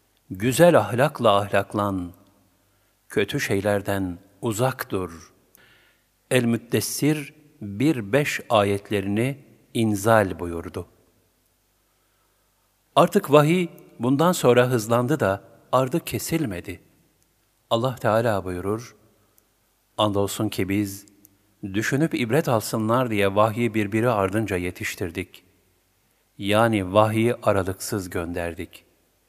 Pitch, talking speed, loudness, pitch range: 110 Hz, 80 wpm, -23 LUFS, 100-125 Hz